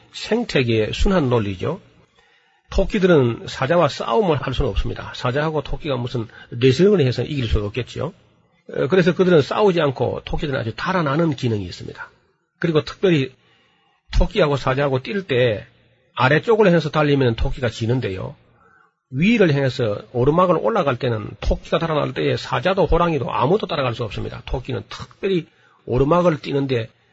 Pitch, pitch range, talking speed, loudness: 140 Hz, 120-175 Hz, 355 characters per minute, -20 LUFS